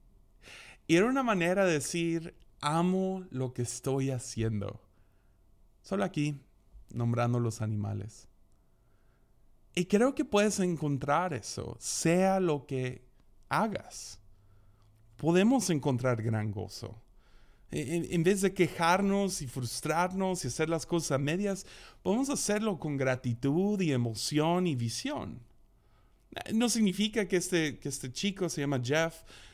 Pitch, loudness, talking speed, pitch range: 145 Hz, -31 LUFS, 120 wpm, 115-180 Hz